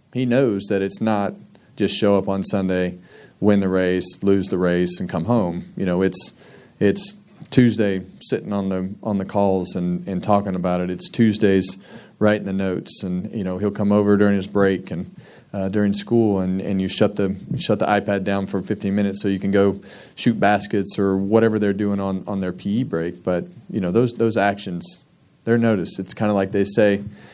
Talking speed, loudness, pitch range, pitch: 205 wpm, -21 LUFS, 95-105 Hz, 100 Hz